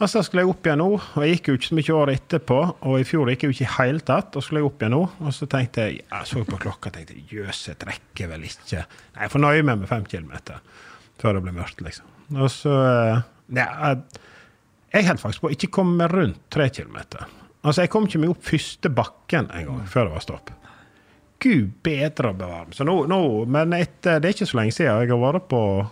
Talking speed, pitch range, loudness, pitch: 225 wpm, 110-165 Hz, -22 LUFS, 140 Hz